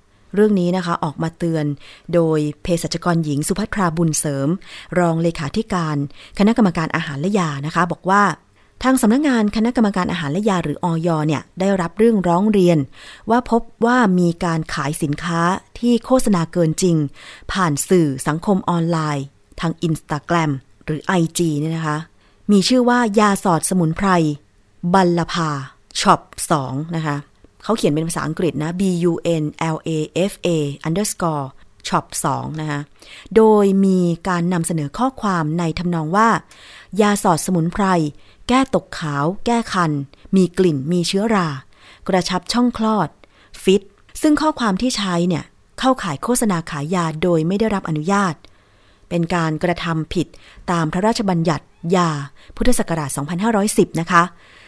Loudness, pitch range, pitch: -19 LUFS, 155-195 Hz, 170 Hz